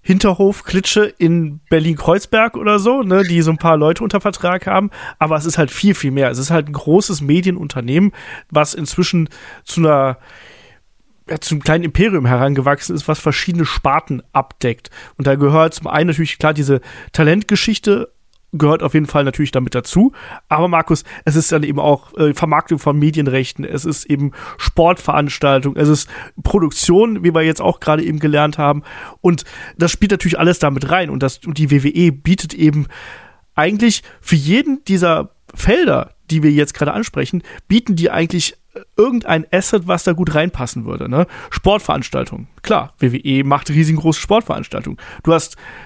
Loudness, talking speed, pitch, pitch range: -15 LUFS, 165 wpm, 160 Hz, 150-180 Hz